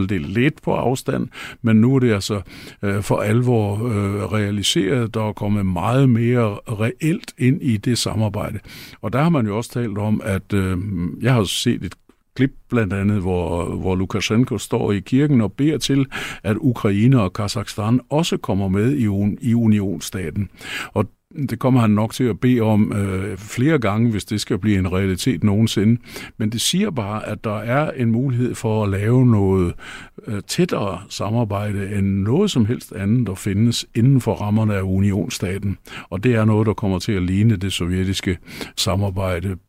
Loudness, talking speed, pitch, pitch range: -20 LUFS, 180 wpm, 110 Hz, 100-120 Hz